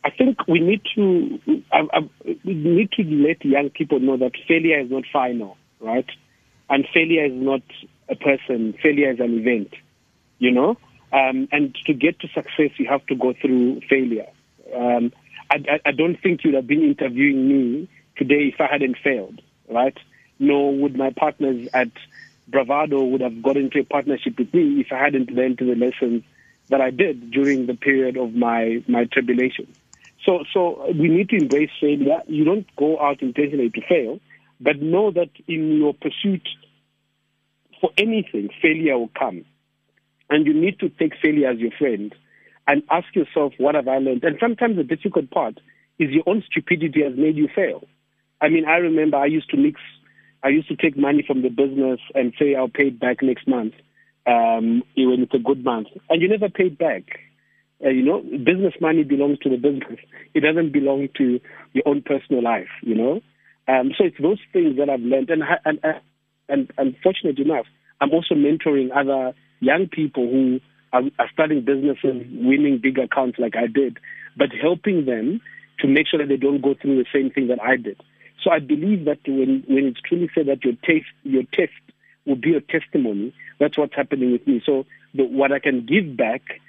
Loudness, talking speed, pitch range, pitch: -20 LUFS, 190 wpm, 130-165 Hz, 140 Hz